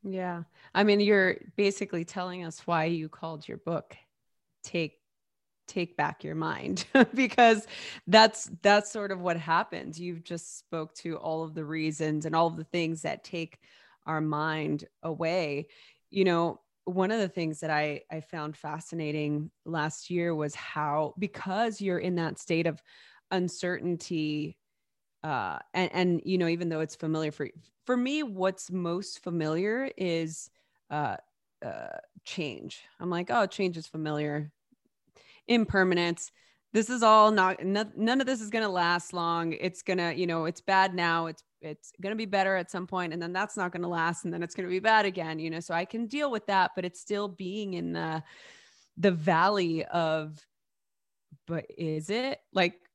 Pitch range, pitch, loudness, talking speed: 160-190 Hz, 175 Hz, -29 LUFS, 170 wpm